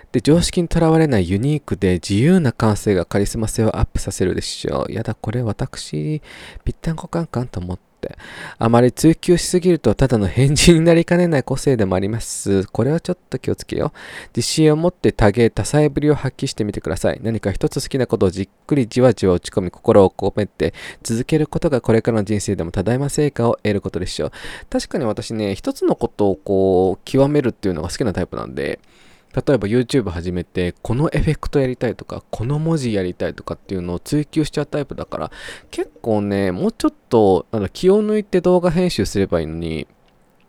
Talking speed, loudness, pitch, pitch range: 425 characters per minute, -19 LUFS, 120 Hz, 100-150 Hz